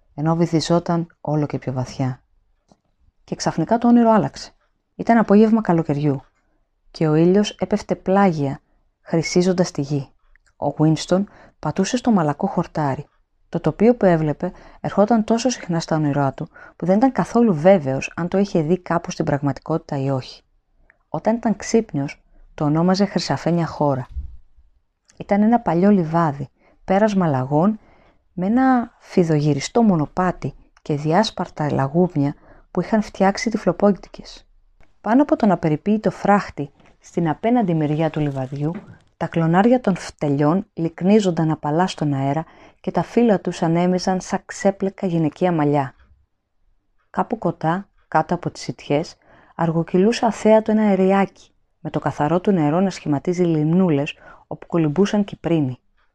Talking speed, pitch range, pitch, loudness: 135 wpm, 150-195 Hz, 170 Hz, -20 LUFS